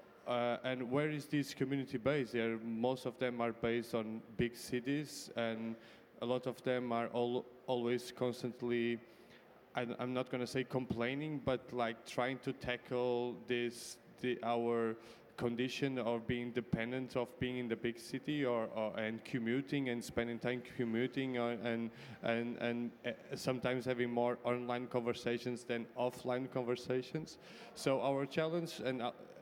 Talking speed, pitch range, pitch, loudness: 155 wpm, 120-130 Hz, 125 Hz, -39 LUFS